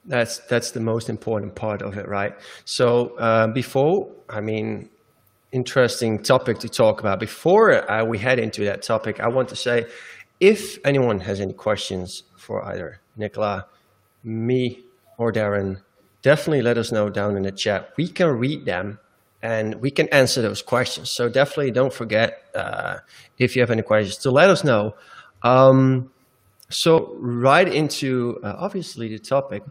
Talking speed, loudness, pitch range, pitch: 165 wpm, -21 LUFS, 105-130 Hz, 120 Hz